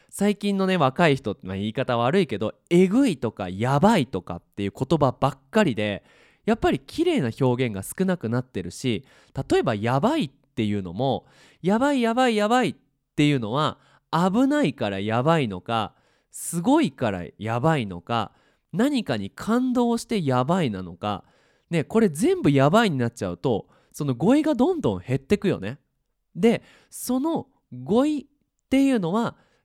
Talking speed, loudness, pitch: 320 characters per minute, -24 LUFS, 145 Hz